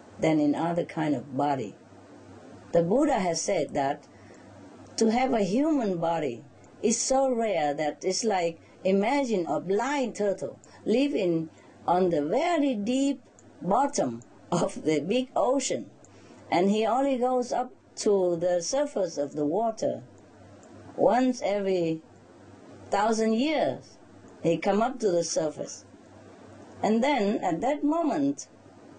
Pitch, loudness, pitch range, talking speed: 220 Hz, -27 LUFS, 175-270 Hz, 130 wpm